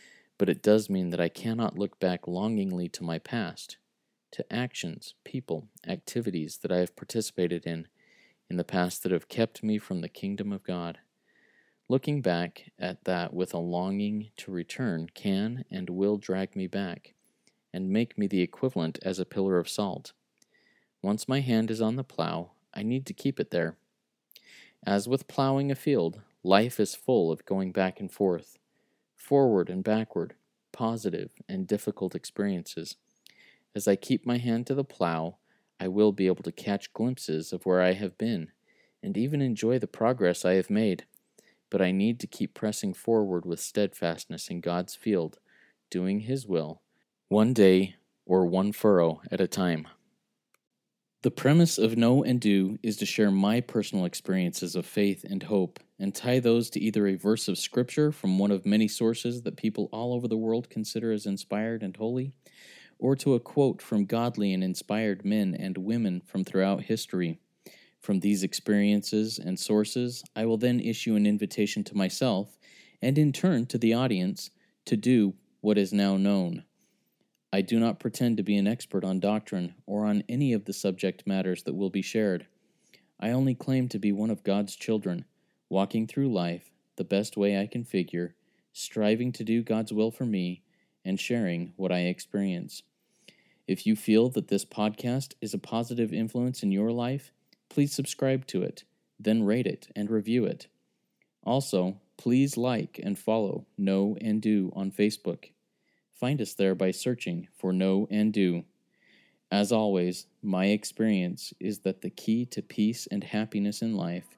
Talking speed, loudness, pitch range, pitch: 175 wpm, -29 LUFS, 95-120 Hz, 105 Hz